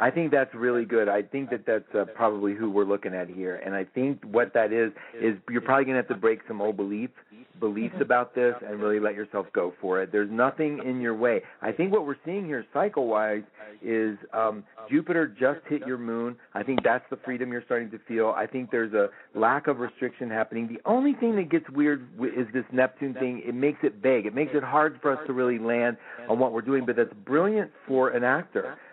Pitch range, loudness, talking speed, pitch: 110-135 Hz, -27 LUFS, 230 wpm, 125 Hz